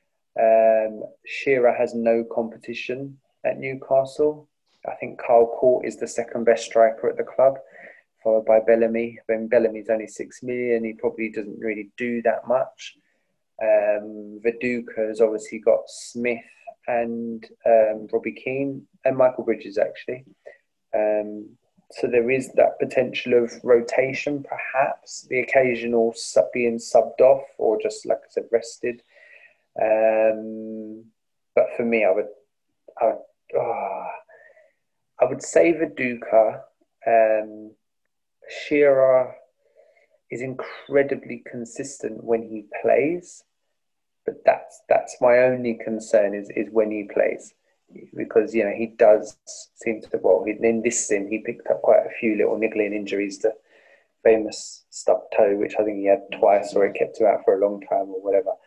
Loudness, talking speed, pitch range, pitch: -22 LUFS, 145 wpm, 110-135 Hz, 115 Hz